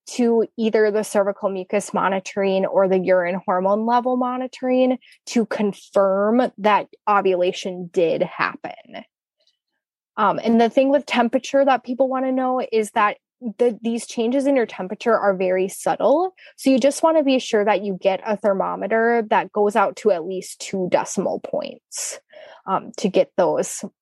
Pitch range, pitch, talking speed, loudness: 200-255 Hz, 225 Hz, 160 wpm, -20 LUFS